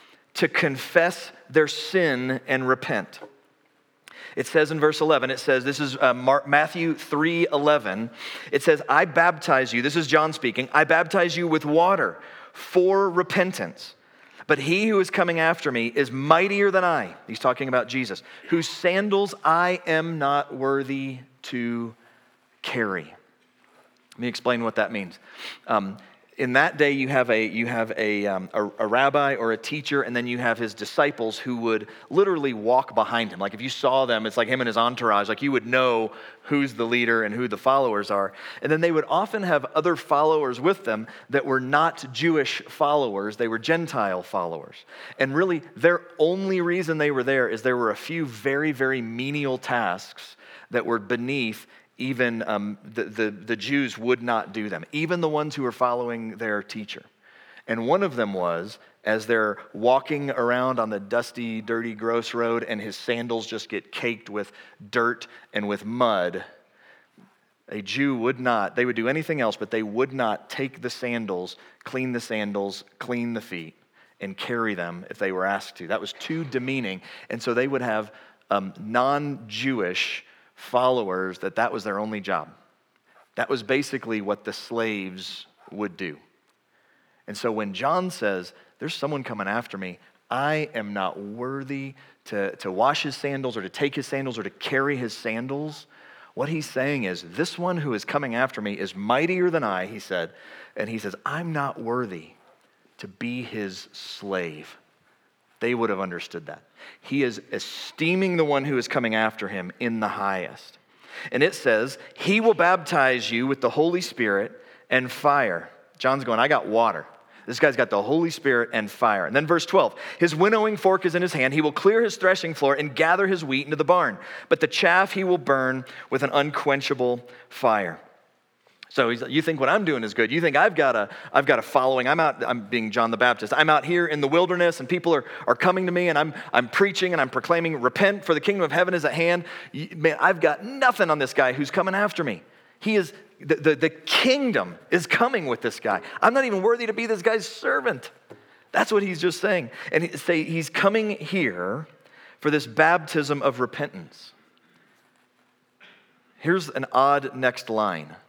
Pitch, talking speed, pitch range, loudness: 135 Hz, 190 wpm, 115-165 Hz, -24 LUFS